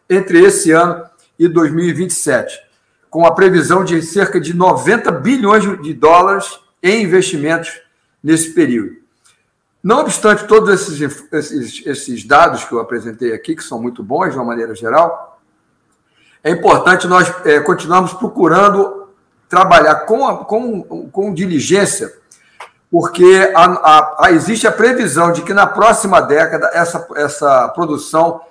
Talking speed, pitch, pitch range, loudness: 135 wpm, 180 Hz, 165-200 Hz, -12 LUFS